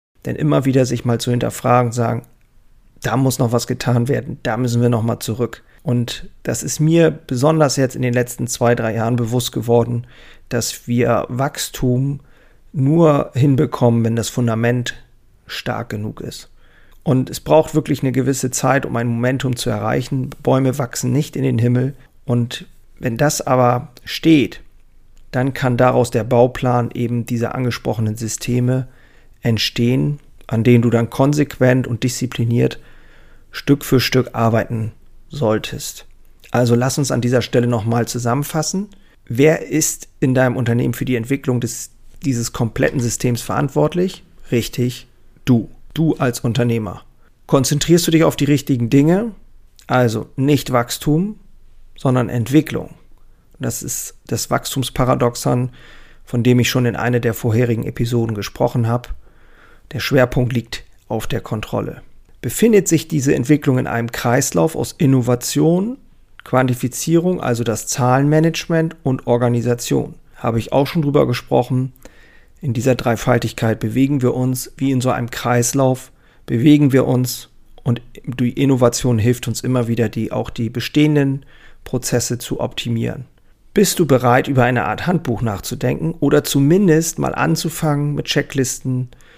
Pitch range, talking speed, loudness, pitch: 120-140 Hz, 140 wpm, -18 LUFS, 125 Hz